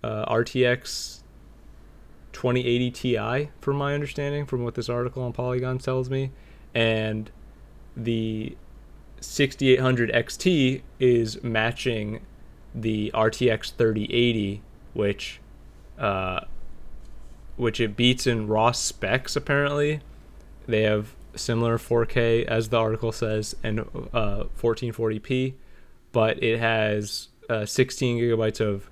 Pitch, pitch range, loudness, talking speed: 115 Hz, 105-125 Hz, -25 LUFS, 105 wpm